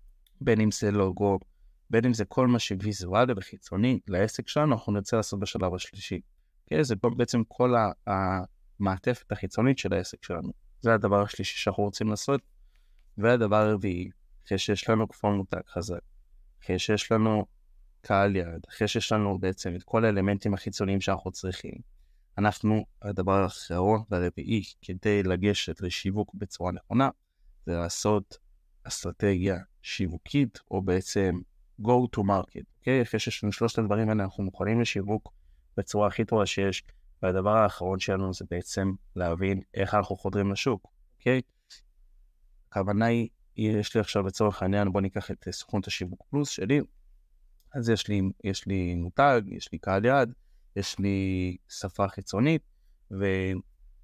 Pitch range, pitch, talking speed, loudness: 95-110 Hz, 100 Hz, 145 wpm, -28 LUFS